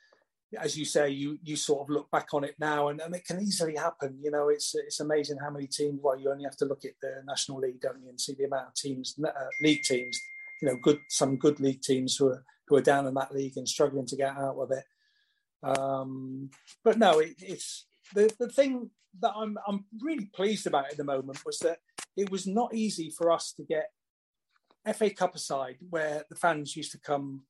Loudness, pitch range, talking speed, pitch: -30 LUFS, 140-200 Hz, 230 wpm, 150 Hz